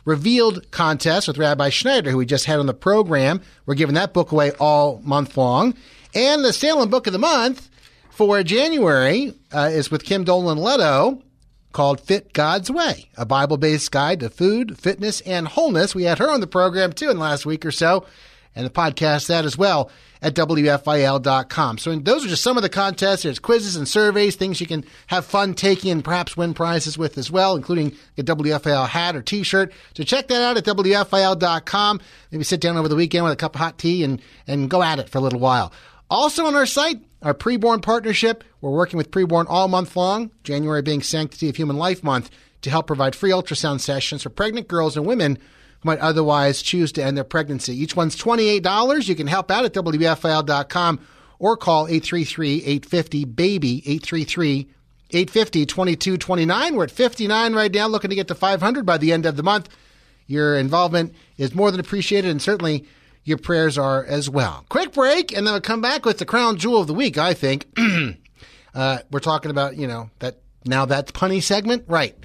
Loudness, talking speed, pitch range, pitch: -19 LUFS, 200 wpm, 145-195 Hz, 165 Hz